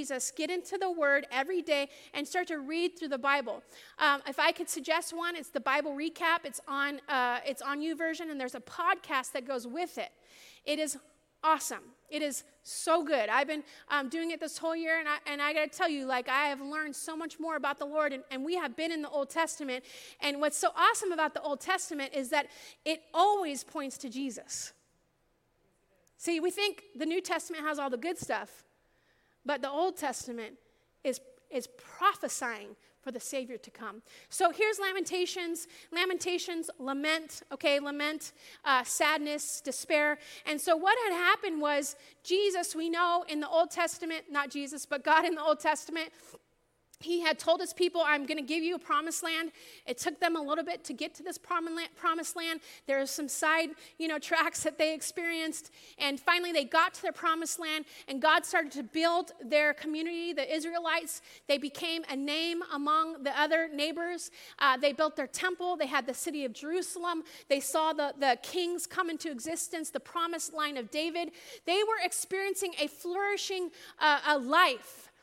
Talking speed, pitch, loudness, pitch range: 190 wpm, 315 Hz, -32 LUFS, 285-340 Hz